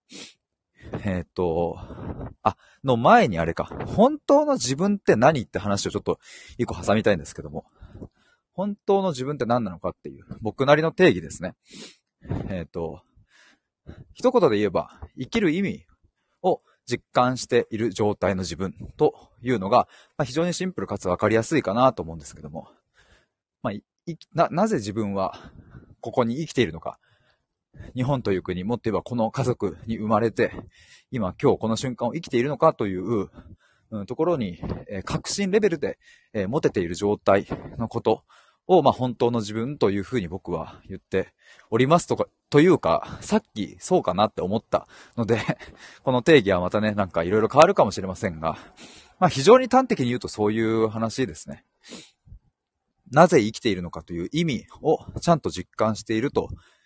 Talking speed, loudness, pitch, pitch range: 325 characters per minute, -23 LUFS, 115 Hz, 100-155 Hz